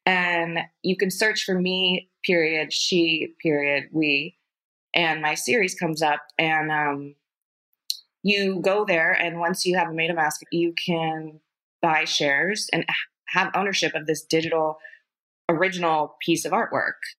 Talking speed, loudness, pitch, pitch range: 145 wpm, -23 LUFS, 165 Hz, 155-180 Hz